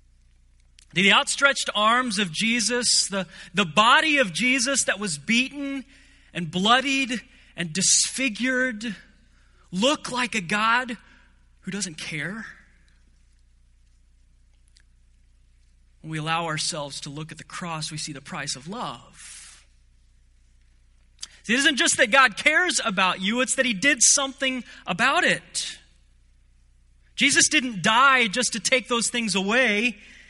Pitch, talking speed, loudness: 190 Hz, 125 wpm, -21 LUFS